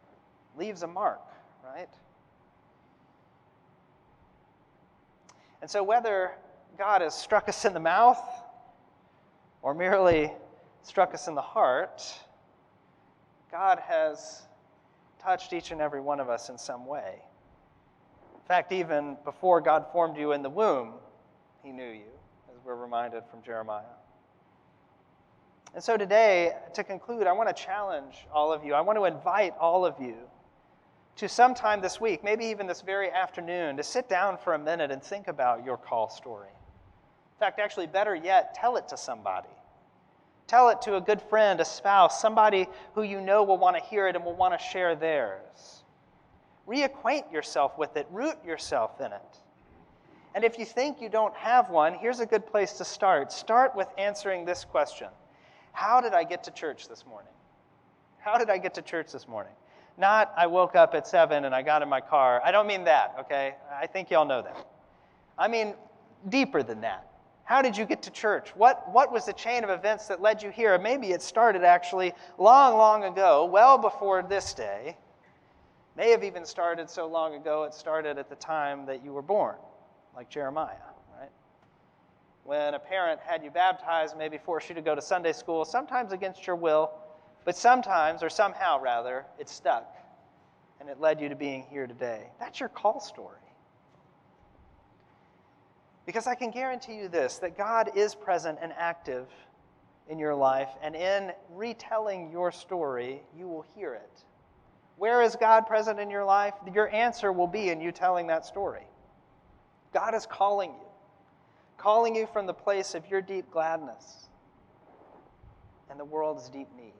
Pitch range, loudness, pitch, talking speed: 155-215 Hz, -27 LUFS, 185 Hz, 170 wpm